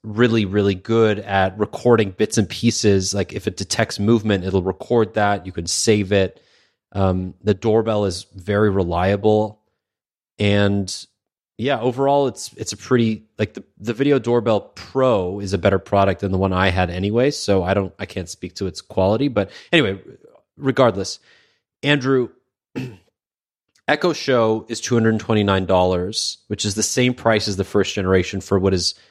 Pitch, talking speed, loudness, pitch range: 105 Hz, 170 wpm, -19 LUFS, 95-115 Hz